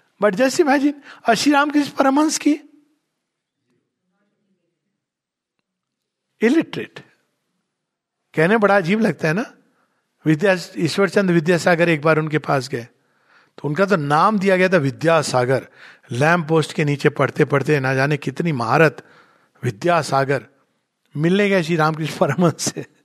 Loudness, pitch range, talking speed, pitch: -18 LUFS, 150-210 Hz, 115 wpm, 170 Hz